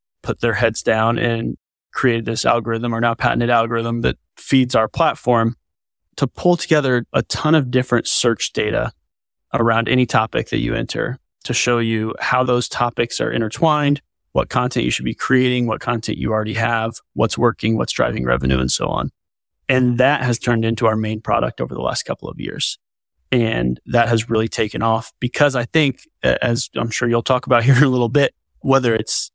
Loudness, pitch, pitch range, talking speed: -18 LUFS, 115 Hz, 110-125 Hz, 190 wpm